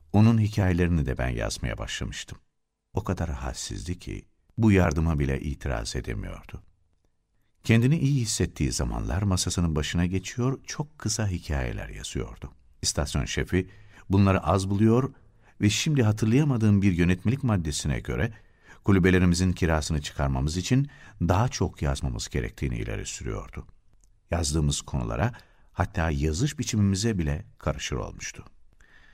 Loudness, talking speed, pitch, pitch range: -26 LUFS, 115 wpm, 95 Hz, 80-110 Hz